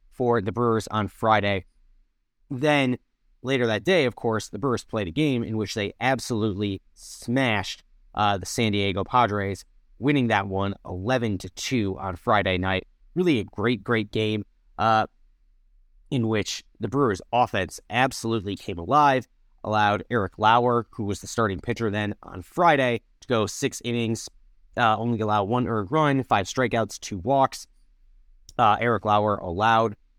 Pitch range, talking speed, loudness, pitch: 95-120 Hz, 155 wpm, -24 LUFS, 110 Hz